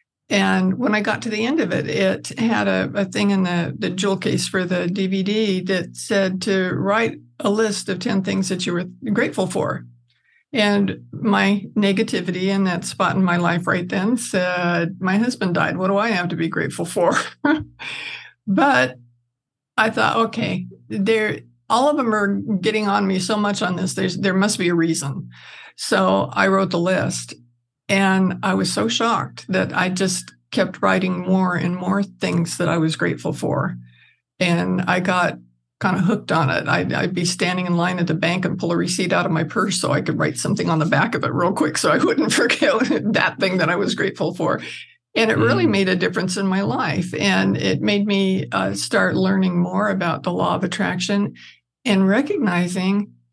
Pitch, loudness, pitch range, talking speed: 185 Hz, -20 LUFS, 175-205 Hz, 200 wpm